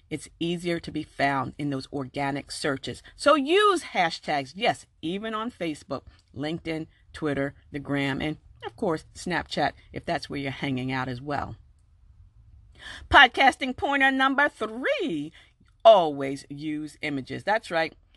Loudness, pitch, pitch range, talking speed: -25 LUFS, 150 Hz, 135-215 Hz, 135 wpm